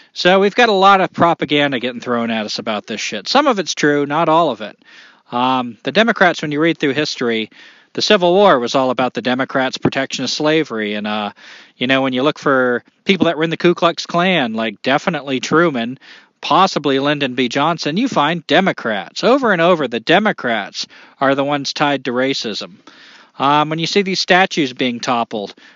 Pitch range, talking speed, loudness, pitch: 130-170 Hz, 200 wpm, -16 LUFS, 145 Hz